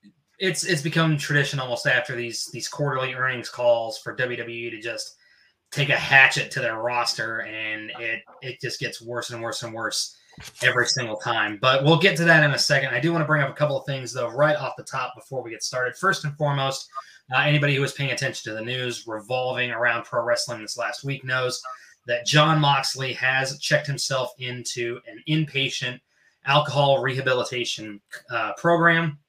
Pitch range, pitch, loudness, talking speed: 120-145 Hz, 130 Hz, -23 LUFS, 195 wpm